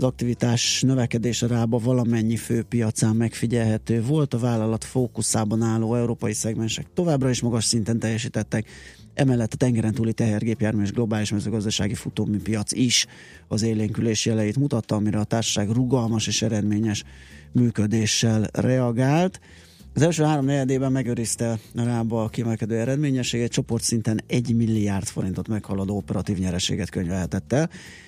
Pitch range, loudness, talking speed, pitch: 105-120 Hz, -23 LUFS, 130 wpm, 115 Hz